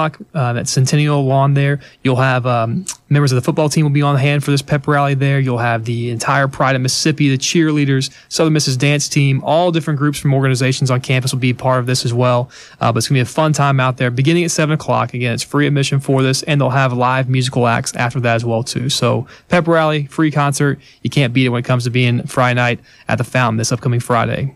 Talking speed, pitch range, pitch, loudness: 250 wpm, 125-145 Hz, 135 Hz, -15 LUFS